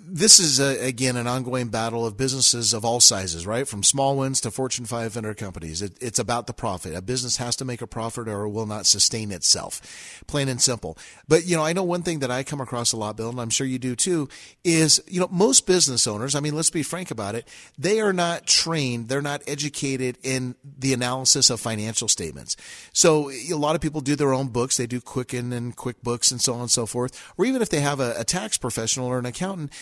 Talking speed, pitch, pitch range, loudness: 240 wpm, 125 Hz, 115-145 Hz, -22 LUFS